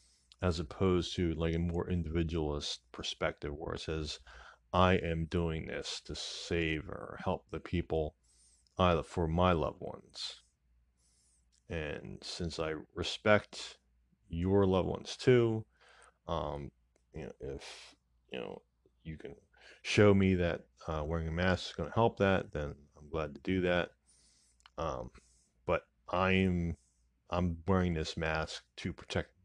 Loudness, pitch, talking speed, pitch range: -34 LUFS, 85 Hz, 140 wpm, 70-90 Hz